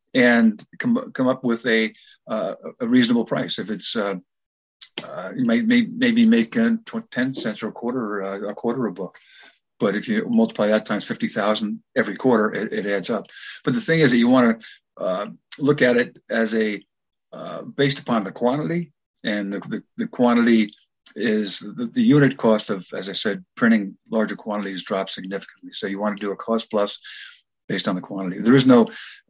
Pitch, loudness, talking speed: 120 Hz, -21 LUFS, 200 wpm